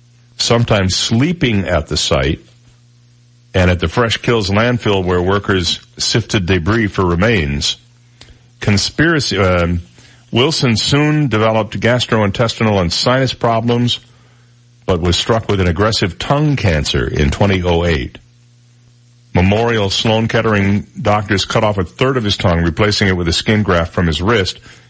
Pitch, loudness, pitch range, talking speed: 110 Hz, -14 LUFS, 95-120 Hz, 135 wpm